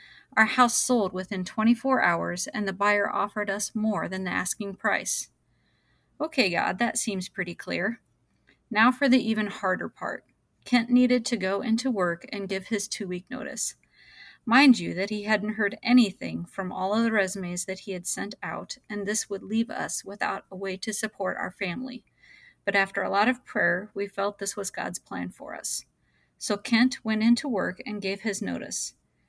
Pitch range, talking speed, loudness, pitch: 195-240 Hz, 190 wpm, -26 LUFS, 210 Hz